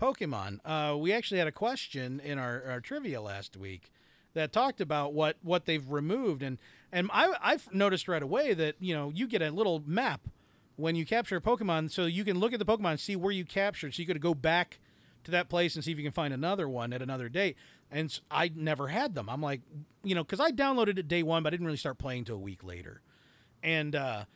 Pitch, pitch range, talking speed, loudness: 160 Hz, 135-190 Hz, 240 wpm, -32 LUFS